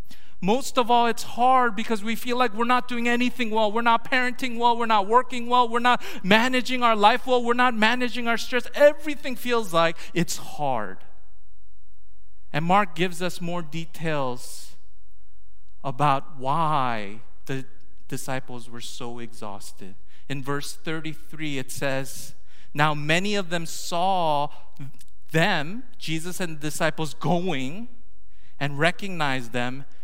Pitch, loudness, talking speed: 165 Hz, -24 LUFS, 140 wpm